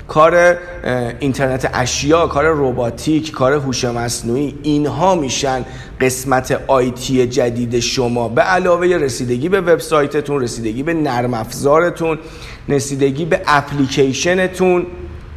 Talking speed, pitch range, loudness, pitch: 100 wpm, 125-160 Hz, -16 LUFS, 140 Hz